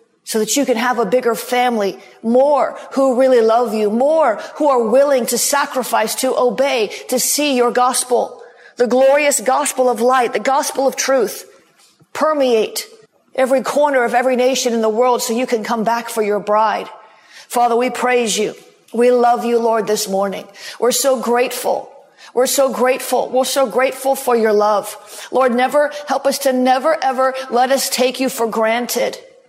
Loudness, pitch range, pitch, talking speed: -16 LUFS, 235-270 Hz, 250 Hz, 175 wpm